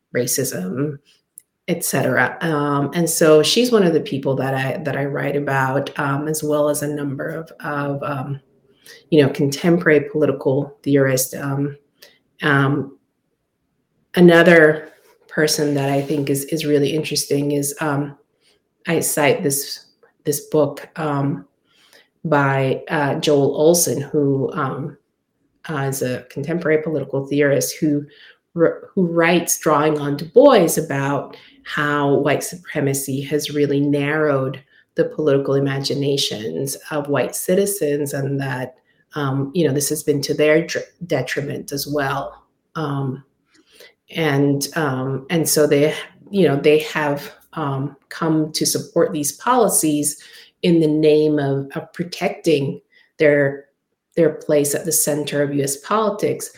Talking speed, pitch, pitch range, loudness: 135 wpm, 145 Hz, 140-155 Hz, -19 LUFS